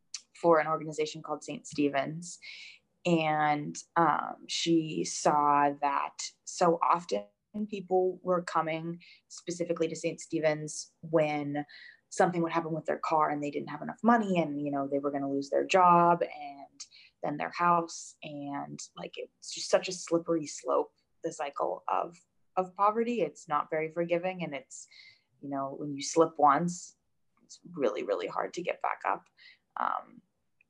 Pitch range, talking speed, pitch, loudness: 150-175 Hz, 155 wpm, 165 Hz, -30 LUFS